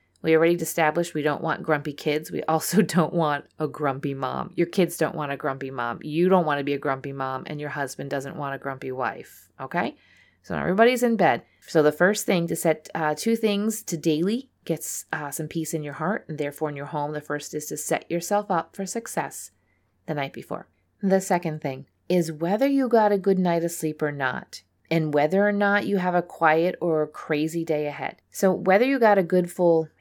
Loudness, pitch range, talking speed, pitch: -24 LUFS, 150-180 Hz, 225 wpm, 160 Hz